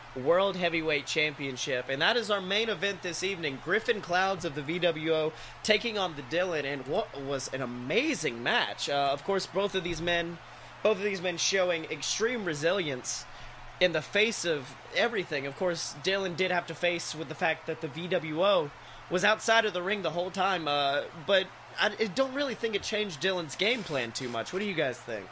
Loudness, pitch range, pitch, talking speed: -29 LUFS, 150-195 Hz, 175 Hz, 200 wpm